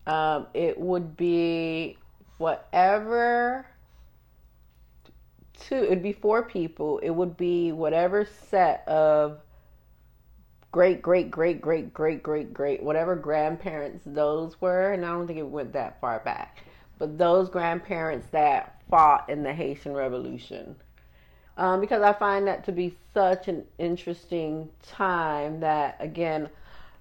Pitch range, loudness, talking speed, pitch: 145-180 Hz, -26 LUFS, 130 wpm, 165 Hz